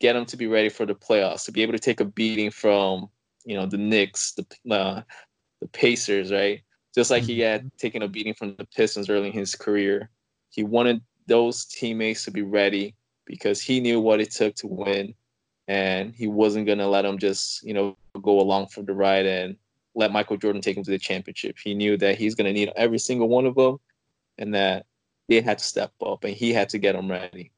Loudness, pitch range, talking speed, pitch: -24 LUFS, 100-115 Hz, 220 wpm, 105 Hz